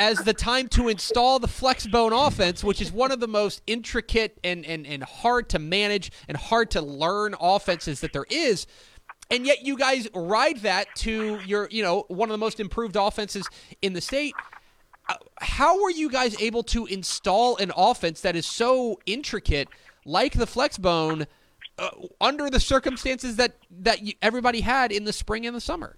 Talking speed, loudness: 180 wpm, -24 LUFS